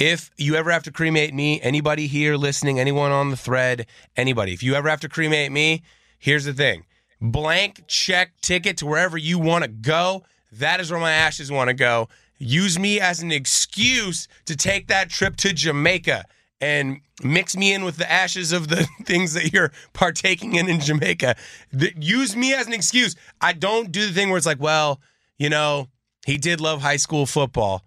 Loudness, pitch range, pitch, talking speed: -20 LUFS, 145-180 Hz, 160 Hz, 195 wpm